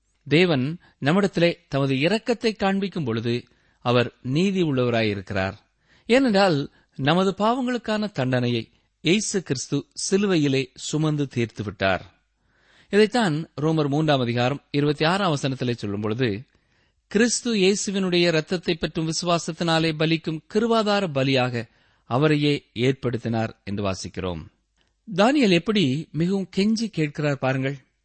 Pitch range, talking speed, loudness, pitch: 125-190 Hz, 90 wpm, -23 LUFS, 150 Hz